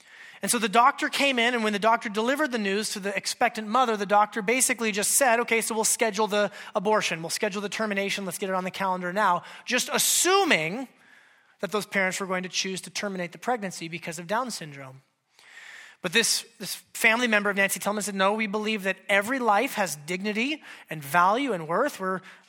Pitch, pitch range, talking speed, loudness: 210 Hz, 185-230 Hz, 210 wpm, -25 LUFS